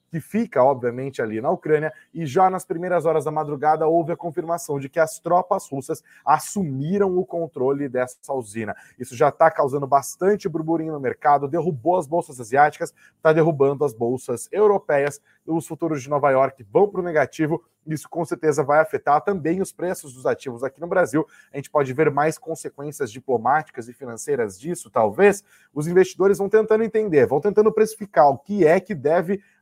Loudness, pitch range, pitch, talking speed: -21 LUFS, 145-185 Hz, 160 Hz, 180 wpm